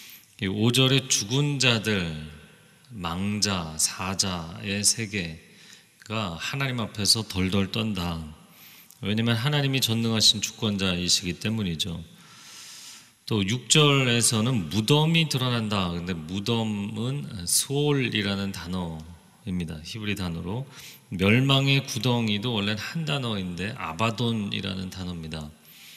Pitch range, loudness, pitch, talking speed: 95-125 Hz, -25 LUFS, 105 Hz, 245 characters per minute